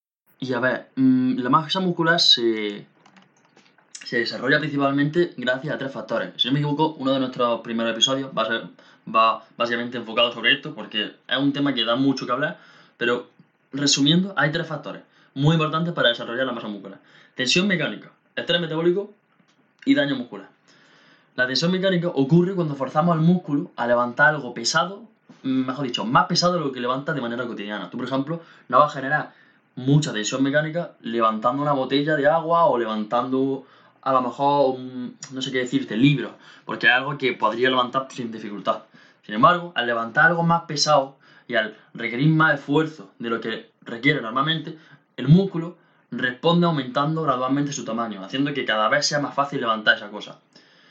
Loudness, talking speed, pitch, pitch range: -22 LUFS, 175 wpm, 140 Hz, 125-165 Hz